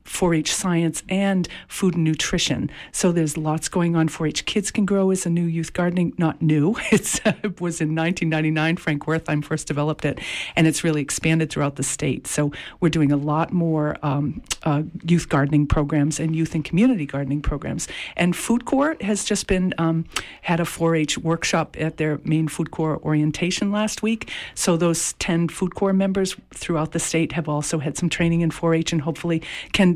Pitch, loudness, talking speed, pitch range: 165 Hz, -22 LUFS, 190 wpm, 155-180 Hz